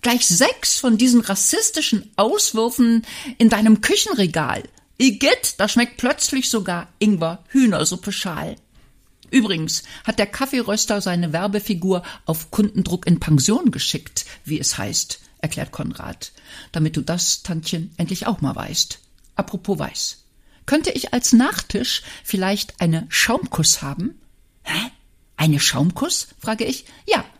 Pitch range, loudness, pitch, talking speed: 175-240 Hz, -19 LUFS, 205 Hz, 125 wpm